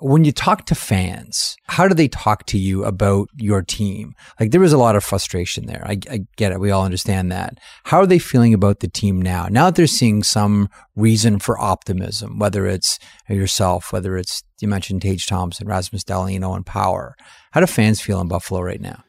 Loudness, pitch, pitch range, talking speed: -18 LUFS, 105 Hz, 95-115 Hz, 210 wpm